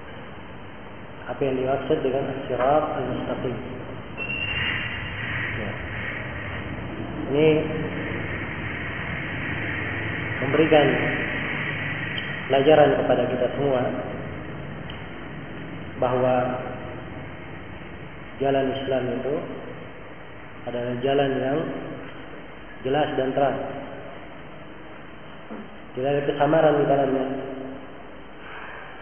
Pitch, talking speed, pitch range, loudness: 130 Hz, 60 wpm, 125-140 Hz, -25 LUFS